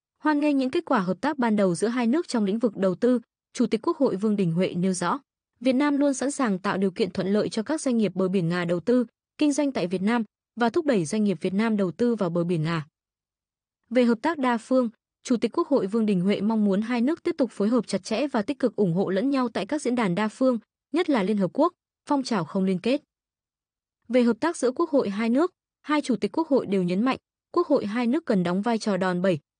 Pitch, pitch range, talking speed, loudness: 230 Hz, 195-265 Hz, 270 wpm, -25 LUFS